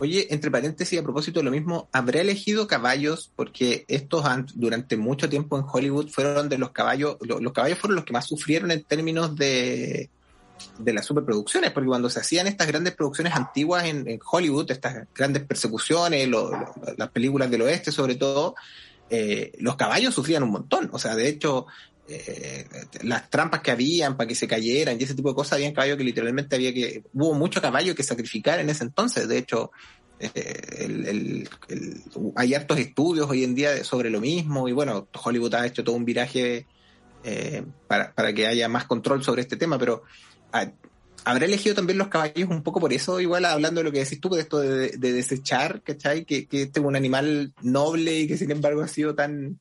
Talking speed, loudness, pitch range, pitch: 205 wpm, -25 LUFS, 125-155 Hz, 140 Hz